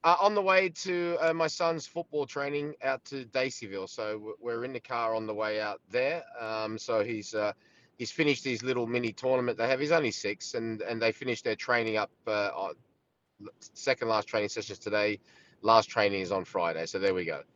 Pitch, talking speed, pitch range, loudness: 120 Hz, 210 wpm, 110-145 Hz, -30 LUFS